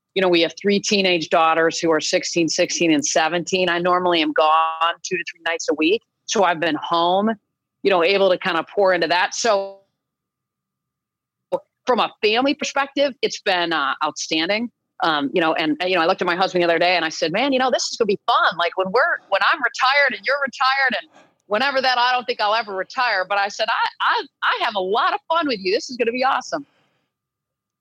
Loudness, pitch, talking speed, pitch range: -19 LUFS, 190 Hz, 235 wpm, 170-250 Hz